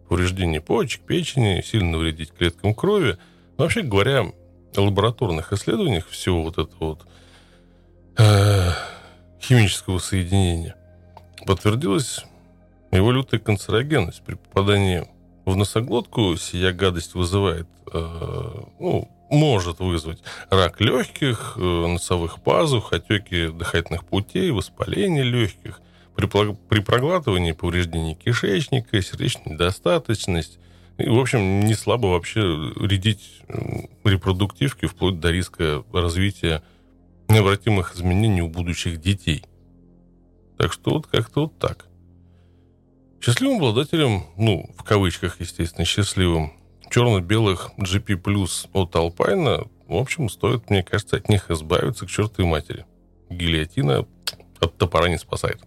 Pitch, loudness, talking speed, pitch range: 95 Hz, -22 LUFS, 110 wpm, 85-110 Hz